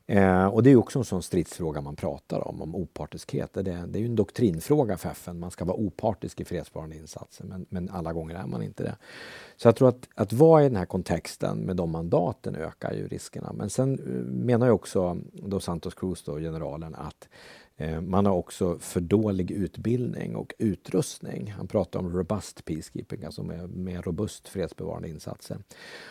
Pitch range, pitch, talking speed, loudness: 85-105 Hz, 90 Hz, 185 wpm, -27 LUFS